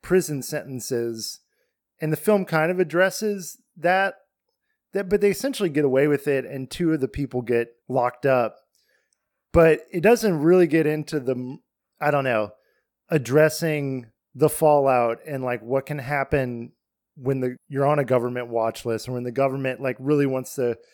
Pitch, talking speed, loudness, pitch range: 145 Hz, 170 wpm, -23 LUFS, 125-165 Hz